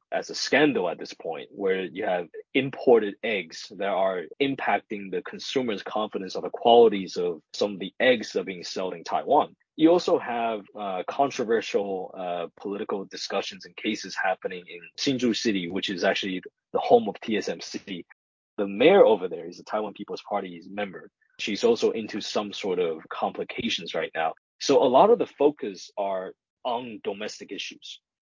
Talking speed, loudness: 175 wpm, -26 LUFS